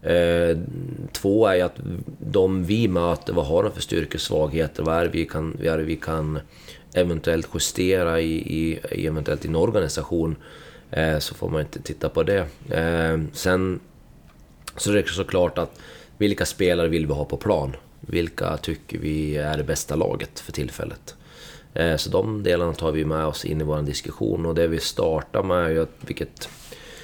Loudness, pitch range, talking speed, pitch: -24 LUFS, 80-85 Hz, 180 wpm, 80 Hz